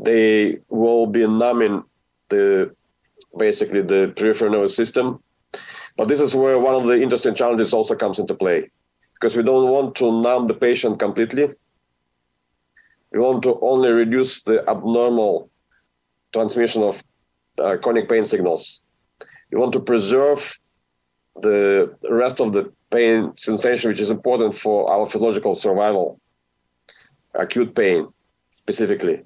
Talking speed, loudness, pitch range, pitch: 135 wpm, -19 LUFS, 95-130 Hz, 115 Hz